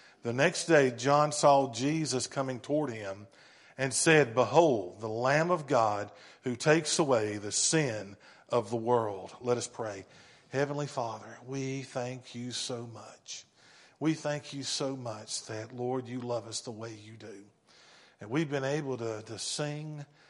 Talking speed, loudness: 165 wpm, -30 LUFS